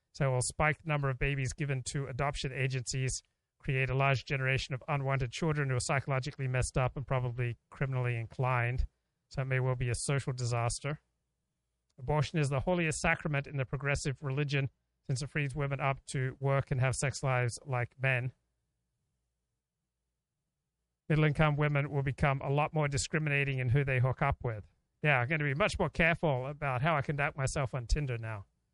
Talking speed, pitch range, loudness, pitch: 185 wpm, 125-145 Hz, -32 LUFS, 135 Hz